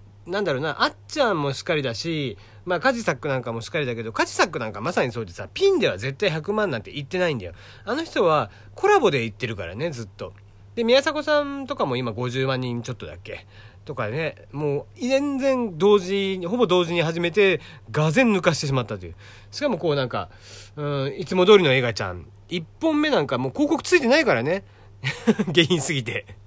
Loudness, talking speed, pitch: -23 LUFS, 410 characters per minute, 145 Hz